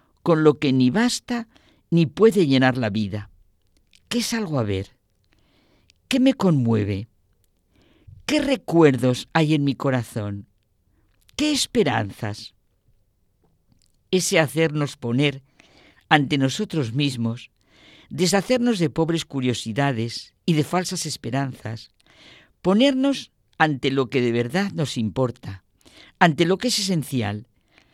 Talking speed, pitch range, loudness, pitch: 115 wpm, 105-170 Hz, -22 LUFS, 135 Hz